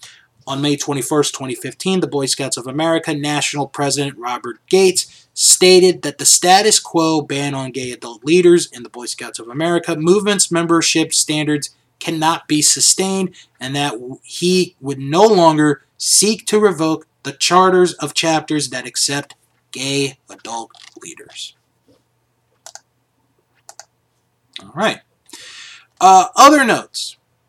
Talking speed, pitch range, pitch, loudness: 125 wpm, 140-180 Hz, 155 Hz, -14 LUFS